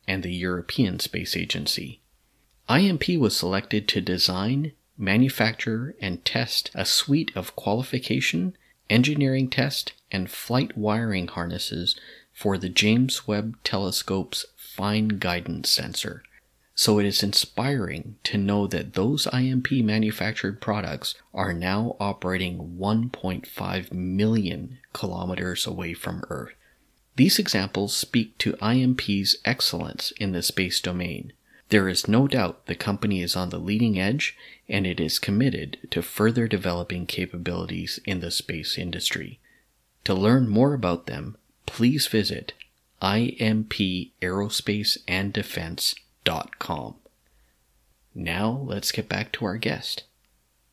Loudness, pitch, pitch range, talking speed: -25 LUFS, 100 Hz, 90-115 Hz, 115 wpm